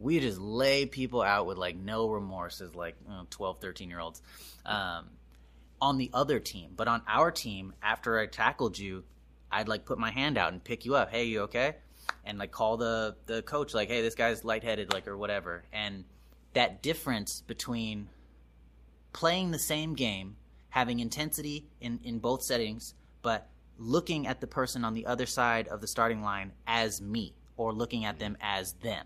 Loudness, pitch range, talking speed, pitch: -32 LUFS, 95-120 Hz, 185 wpm, 110 Hz